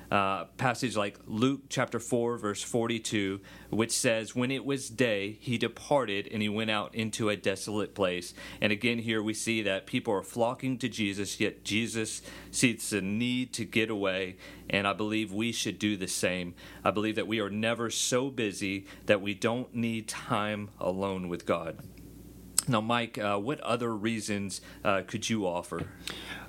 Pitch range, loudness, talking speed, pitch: 100-115 Hz, -31 LUFS, 170 wpm, 110 Hz